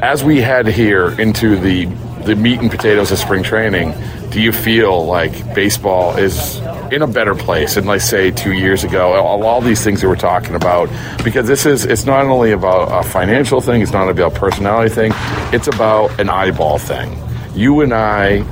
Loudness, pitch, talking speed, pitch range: -13 LUFS, 110 Hz, 195 wpm, 95-115 Hz